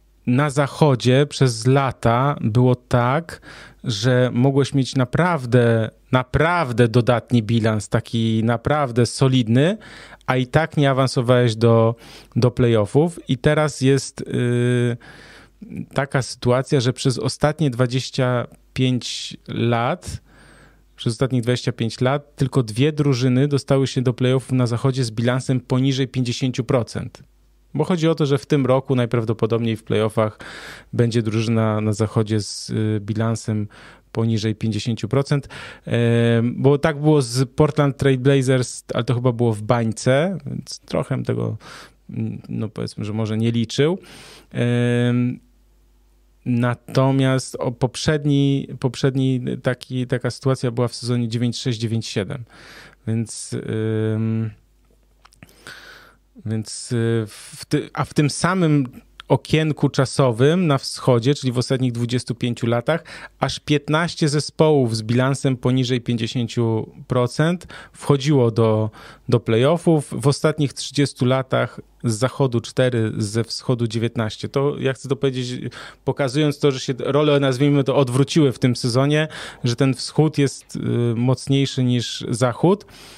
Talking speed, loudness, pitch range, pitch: 120 wpm, -20 LUFS, 120-140 Hz, 130 Hz